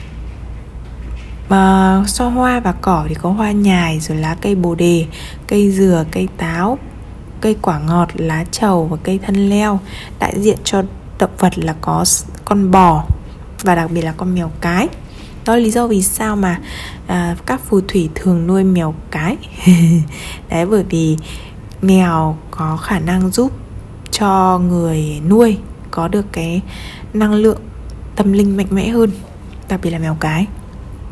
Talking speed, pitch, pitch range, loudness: 160 wpm, 185 Hz, 165-200 Hz, -15 LUFS